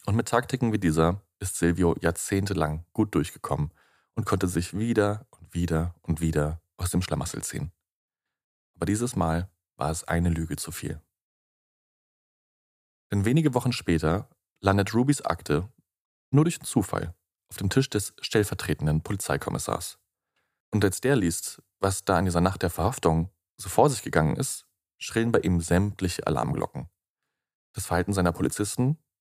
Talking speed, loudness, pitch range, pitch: 150 wpm, -27 LUFS, 85-105 Hz, 95 Hz